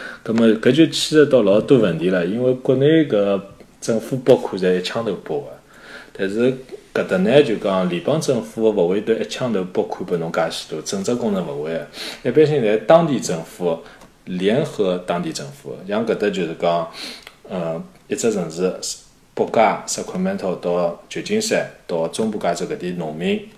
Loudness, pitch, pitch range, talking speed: -19 LUFS, 115 Hz, 95-155 Hz, 260 characters per minute